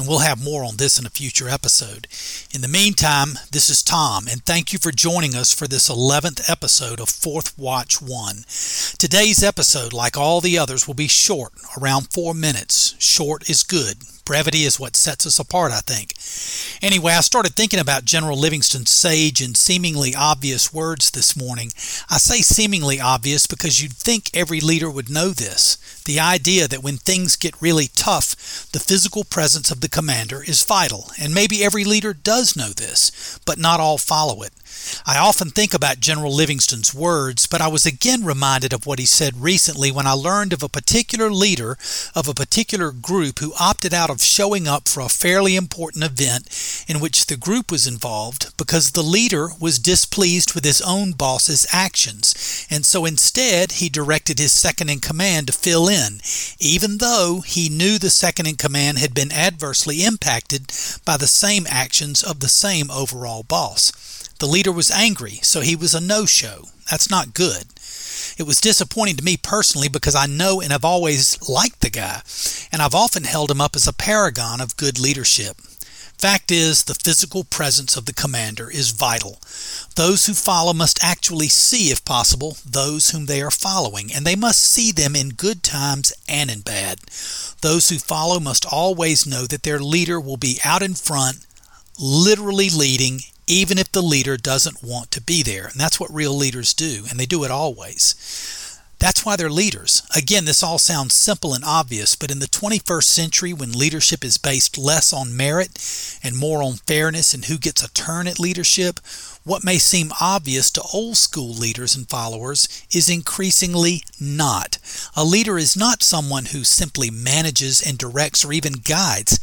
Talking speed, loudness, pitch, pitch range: 185 wpm, -16 LUFS, 155 Hz, 135-175 Hz